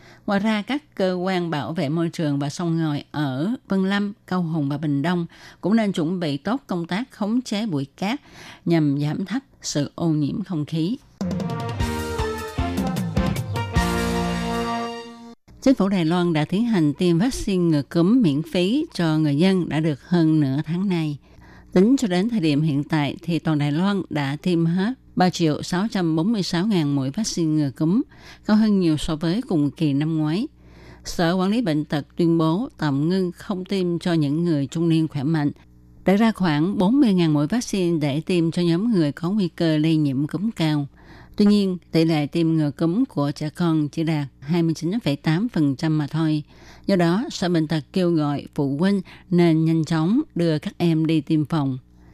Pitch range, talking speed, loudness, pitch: 150-190 Hz, 185 wpm, -22 LUFS, 165 Hz